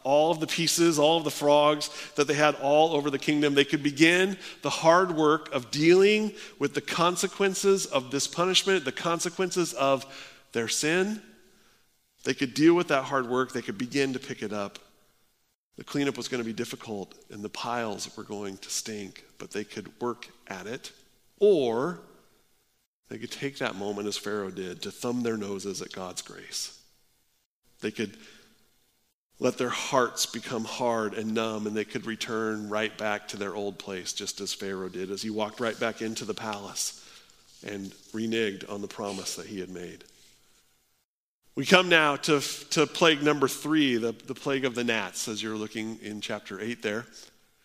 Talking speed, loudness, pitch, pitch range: 185 wpm, -27 LUFS, 130 Hz, 110-155 Hz